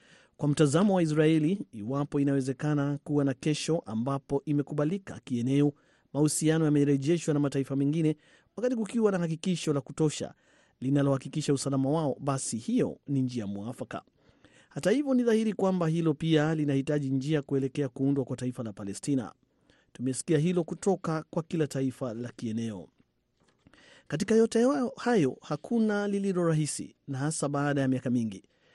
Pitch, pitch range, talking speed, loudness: 145 Hz, 135-165 Hz, 140 wpm, -29 LUFS